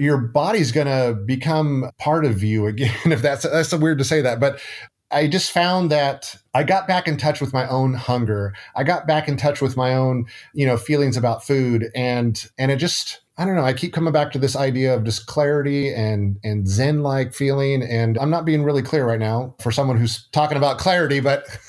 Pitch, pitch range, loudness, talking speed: 140 Hz, 125-150 Hz, -20 LUFS, 225 wpm